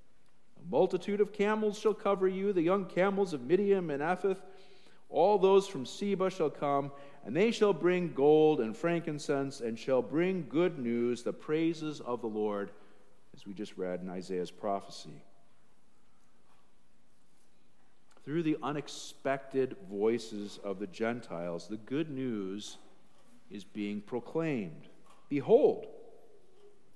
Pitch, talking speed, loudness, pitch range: 155 Hz, 130 wpm, -32 LUFS, 115-195 Hz